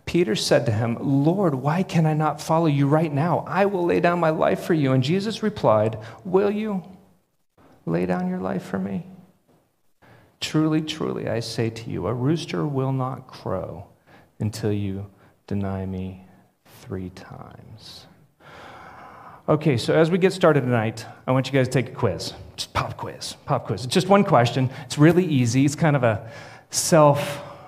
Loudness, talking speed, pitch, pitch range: -22 LUFS, 175 wpm, 140 Hz, 115-165 Hz